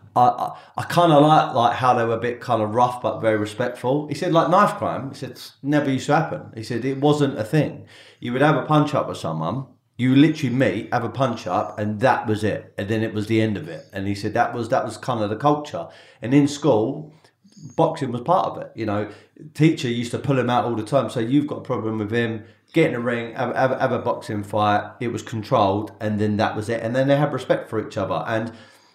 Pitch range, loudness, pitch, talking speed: 110-145 Hz, -21 LUFS, 125 Hz, 260 wpm